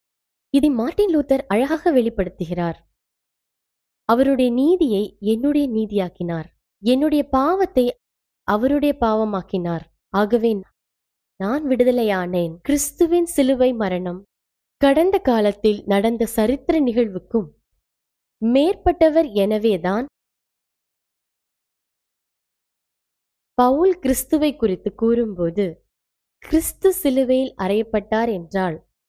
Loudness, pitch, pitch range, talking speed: -20 LUFS, 230 Hz, 195-280 Hz, 70 wpm